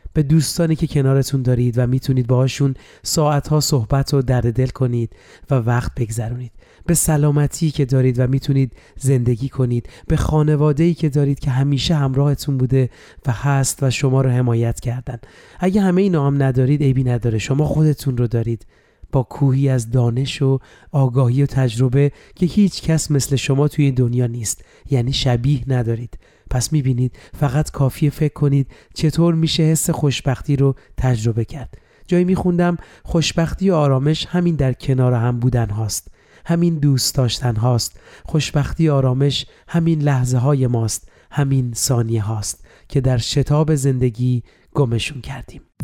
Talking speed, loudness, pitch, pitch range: 150 wpm, -18 LUFS, 135 Hz, 125-150 Hz